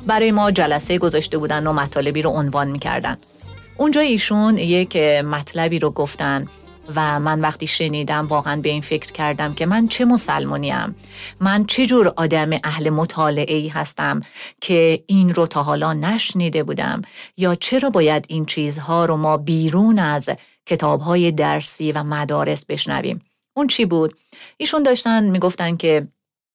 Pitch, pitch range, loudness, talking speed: 160 Hz, 150-190 Hz, -18 LUFS, 150 wpm